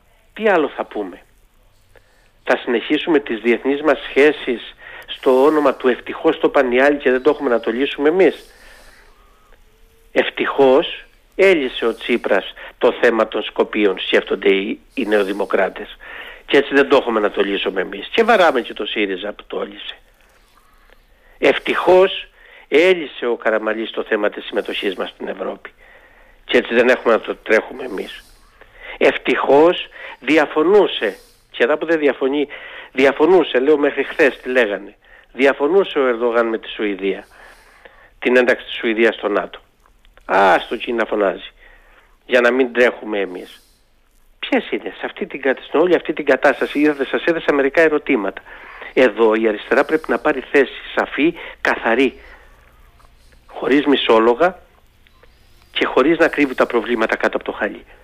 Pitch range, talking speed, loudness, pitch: 120-185 Hz, 145 wpm, -17 LUFS, 140 Hz